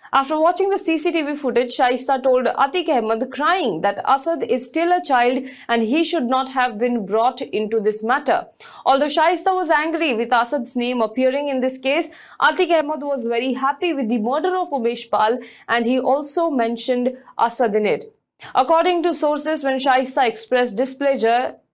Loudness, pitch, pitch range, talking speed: -19 LUFS, 265 Hz, 245-320 Hz, 170 wpm